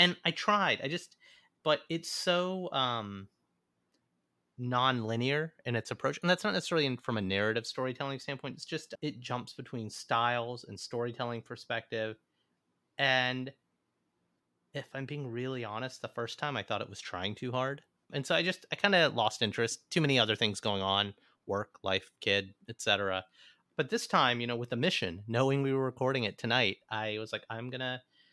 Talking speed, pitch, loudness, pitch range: 180 wpm, 125 Hz, -32 LUFS, 110-140 Hz